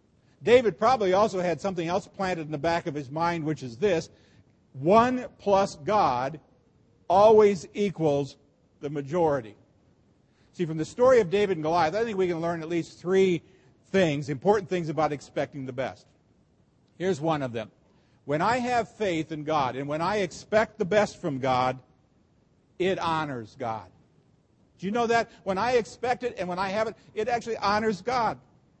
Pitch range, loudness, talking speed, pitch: 150-205 Hz, -26 LUFS, 175 wpm, 175 Hz